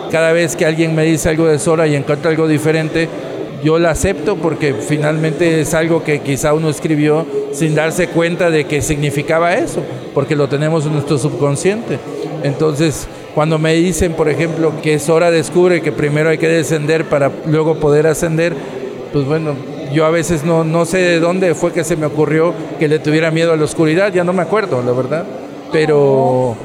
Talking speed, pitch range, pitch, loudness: 190 wpm, 150-165 Hz, 160 Hz, -14 LUFS